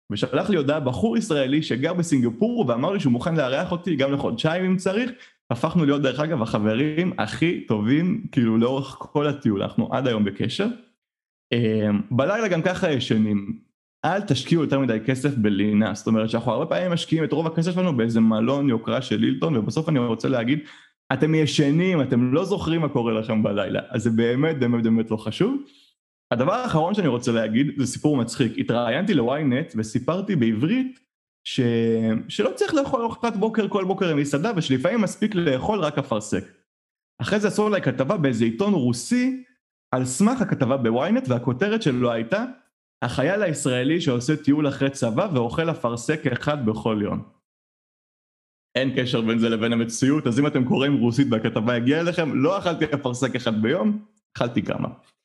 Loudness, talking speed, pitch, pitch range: -23 LUFS, 165 wpm, 140 Hz, 120-175 Hz